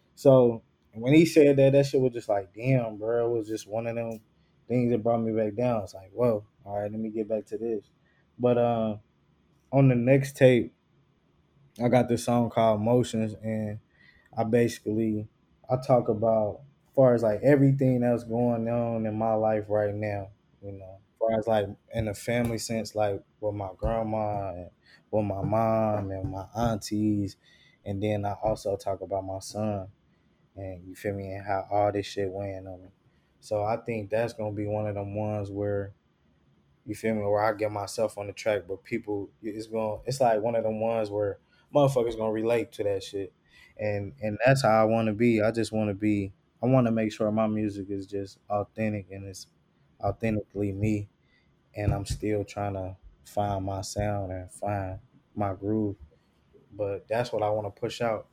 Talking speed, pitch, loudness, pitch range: 200 wpm, 110 Hz, -27 LUFS, 100-115 Hz